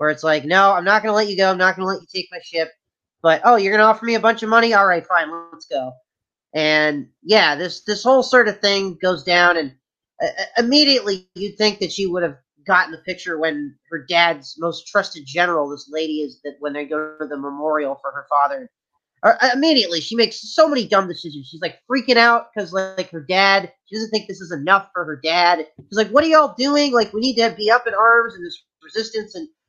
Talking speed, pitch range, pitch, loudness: 245 wpm, 155-220 Hz, 185 Hz, -17 LUFS